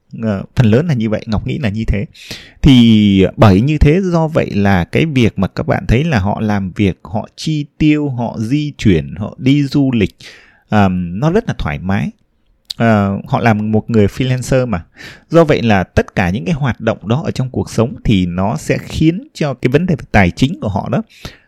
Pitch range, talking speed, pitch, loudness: 100-145 Hz, 220 wpm, 115 Hz, -14 LUFS